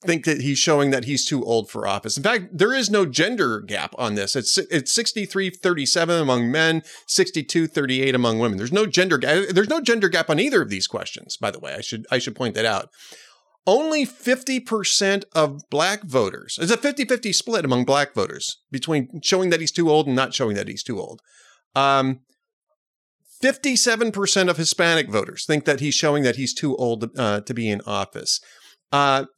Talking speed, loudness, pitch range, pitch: 195 wpm, -21 LUFS, 135-200 Hz, 160 Hz